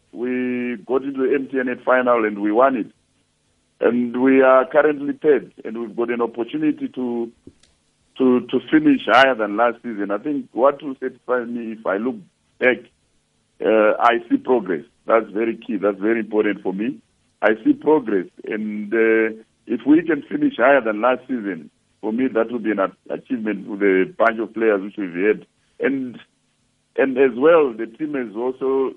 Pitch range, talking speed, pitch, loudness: 110-135 Hz, 180 wpm, 125 Hz, -20 LUFS